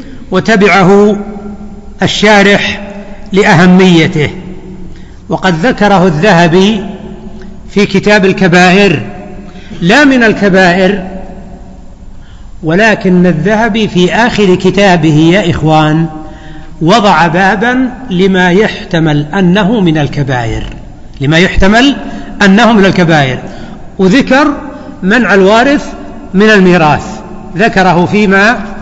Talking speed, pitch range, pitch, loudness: 80 wpm, 180-210 Hz, 195 Hz, -7 LUFS